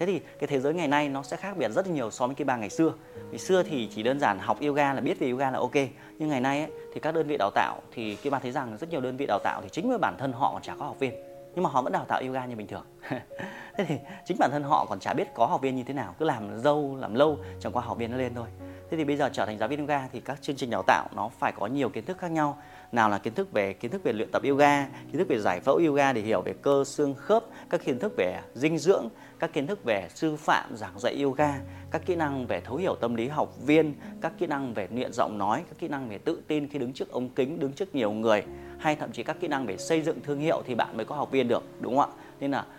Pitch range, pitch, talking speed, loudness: 115-155 Hz, 140 Hz, 305 wpm, -28 LUFS